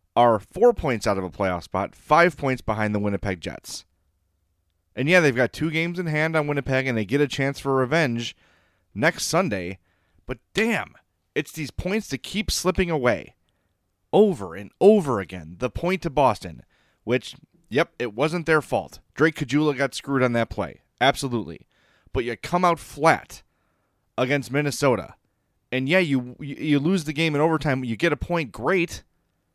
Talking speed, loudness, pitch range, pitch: 175 wpm, -23 LUFS, 110-160 Hz, 135 Hz